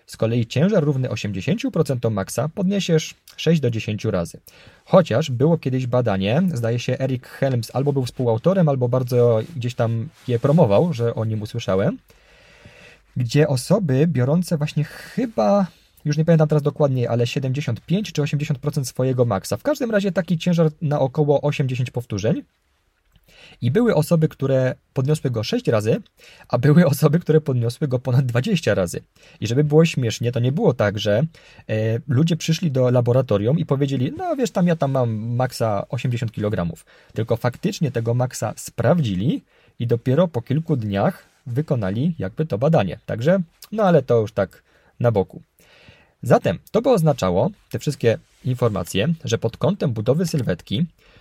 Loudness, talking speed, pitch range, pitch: -21 LUFS, 155 wpm, 120-160 Hz, 135 Hz